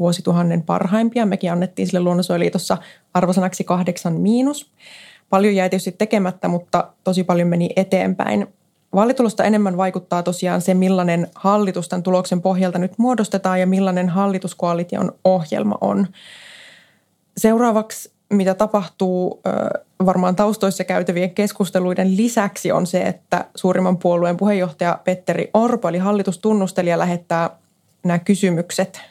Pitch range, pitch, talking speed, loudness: 180-200 Hz, 185 Hz, 115 wpm, -19 LUFS